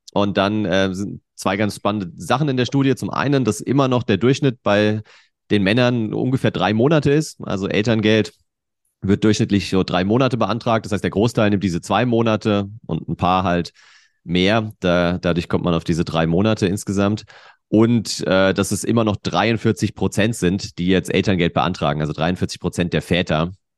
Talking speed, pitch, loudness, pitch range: 185 wpm, 105 Hz, -19 LUFS, 95-115 Hz